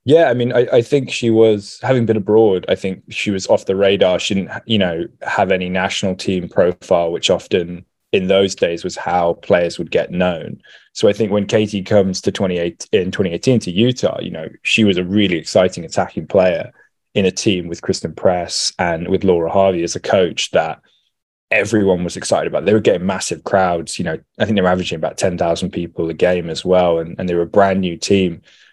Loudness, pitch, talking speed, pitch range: -16 LUFS, 95 Hz, 215 wpm, 90-105 Hz